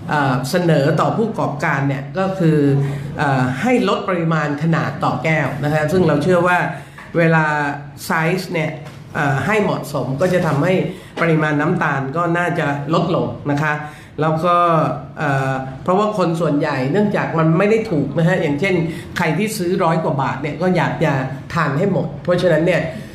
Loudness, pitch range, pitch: -18 LUFS, 145-175 Hz, 160 Hz